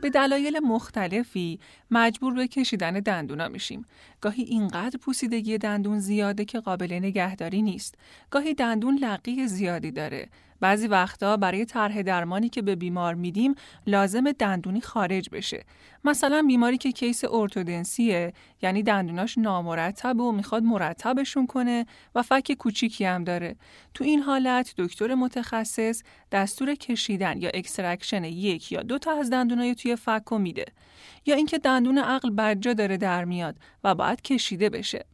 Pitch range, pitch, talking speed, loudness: 190-250 Hz, 225 Hz, 140 wpm, -26 LUFS